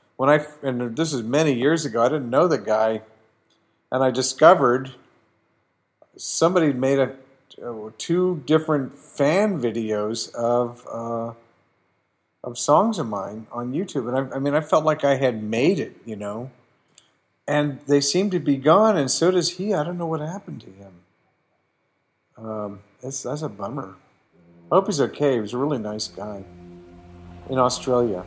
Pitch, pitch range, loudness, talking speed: 130 Hz, 110-150 Hz, -22 LUFS, 165 wpm